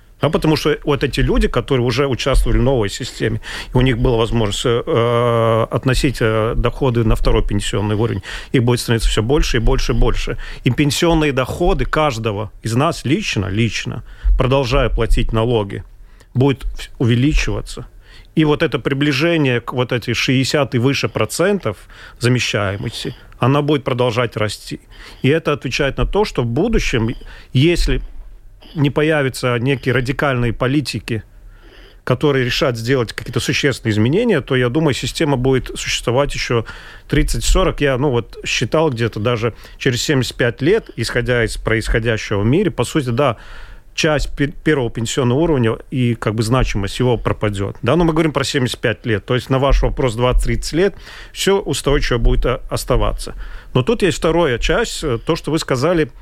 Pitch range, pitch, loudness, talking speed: 115-145 Hz, 125 Hz, -17 LUFS, 155 wpm